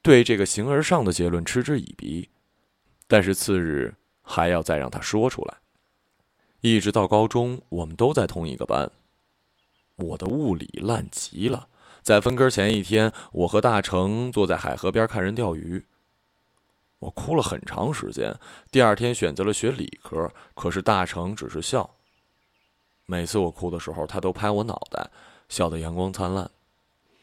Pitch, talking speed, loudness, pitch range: 100 Hz, 235 characters per minute, -24 LUFS, 90-110 Hz